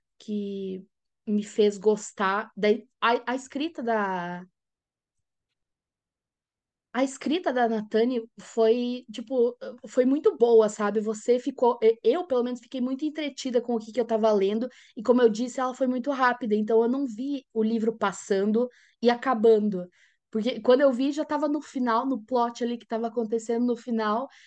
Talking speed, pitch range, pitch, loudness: 165 wpm, 220-255 Hz, 235 Hz, -26 LUFS